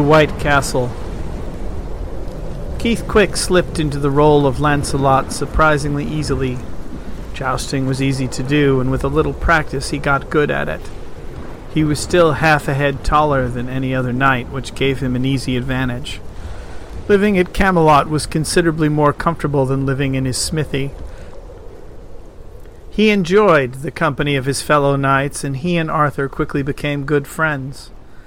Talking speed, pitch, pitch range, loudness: 155 wpm, 140 Hz, 130-150 Hz, -16 LUFS